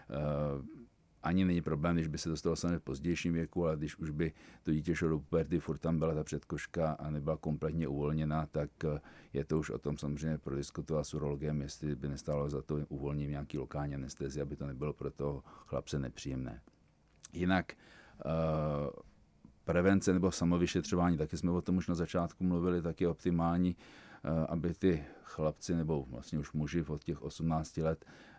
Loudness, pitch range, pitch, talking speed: -36 LUFS, 75-85 Hz, 80 Hz, 180 wpm